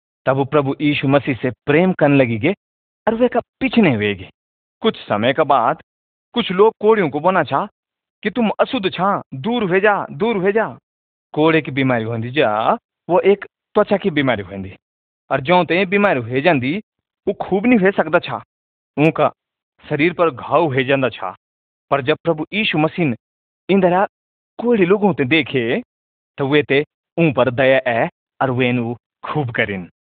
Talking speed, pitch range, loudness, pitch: 160 wpm, 125-195 Hz, -17 LUFS, 150 Hz